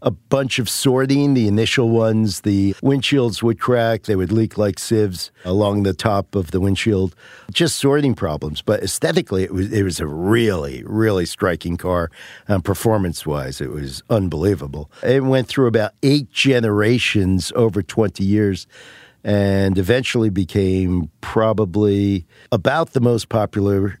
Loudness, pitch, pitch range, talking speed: -18 LUFS, 105 Hz, 95-115 Hz, 150 wpm